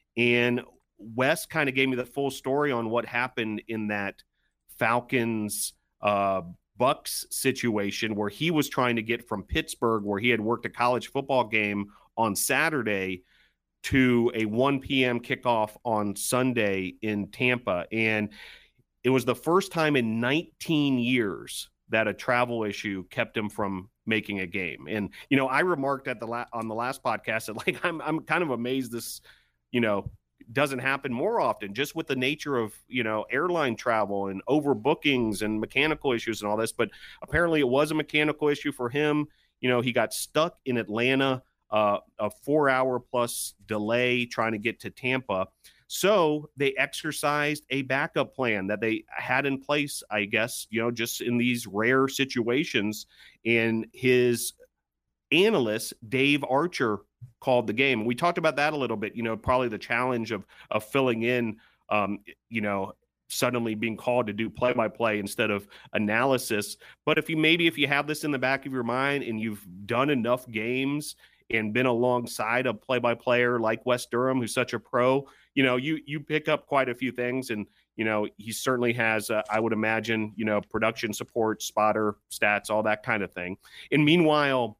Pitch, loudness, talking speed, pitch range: 120 Hz, -27 LUFS, 185 wpm, 110-135 Hz